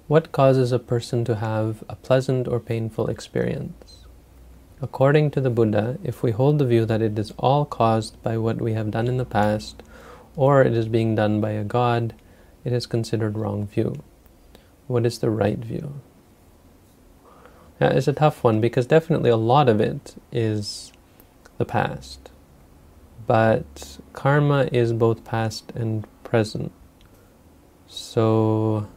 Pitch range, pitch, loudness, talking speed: 100-120 Hz, 115 Hz, -22 LUFS, 150 wpm